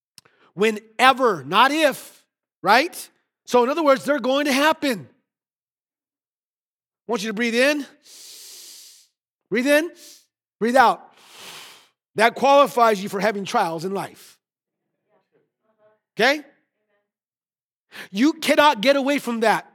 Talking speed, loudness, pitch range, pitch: 110 wpm, -19 LUFS, 215-285 Hz, 250 Hz